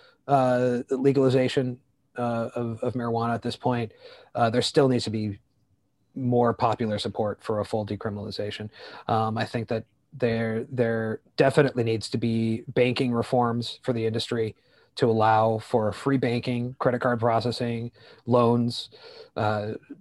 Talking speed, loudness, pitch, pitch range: 140 wpm, -26 LUFS, 120 Hz, 110-125 Hz